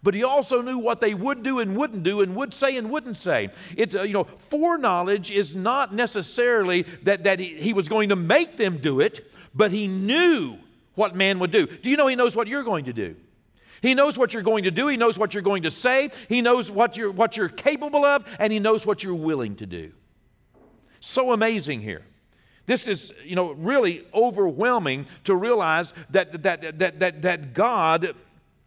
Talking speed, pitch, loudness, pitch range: 210 wpm, 205 Hz, -23 LUFS, 180-245 Hz